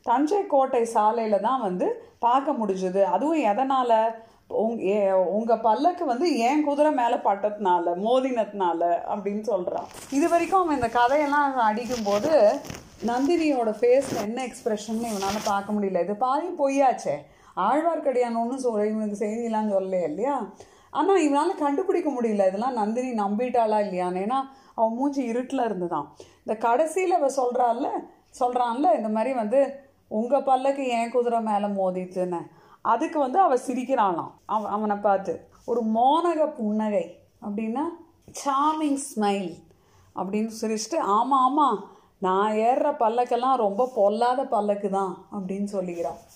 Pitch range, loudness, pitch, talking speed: 205-275 Hz, -24 LUFS, 235 Hz, 125 wpm